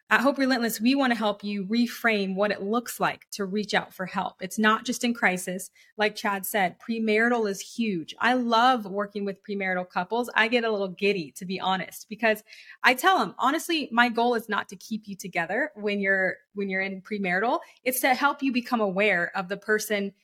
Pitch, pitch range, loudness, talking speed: 210 Hz, 195-240 Hz, -26 LUFS, 210 wpm